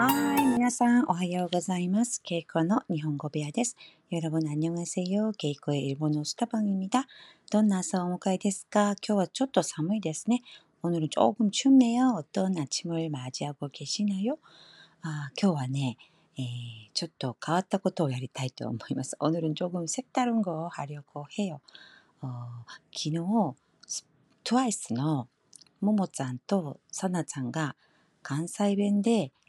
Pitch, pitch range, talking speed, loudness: 175 Hz, 150-205 Hz, 325 characters per minute, -29 LUFS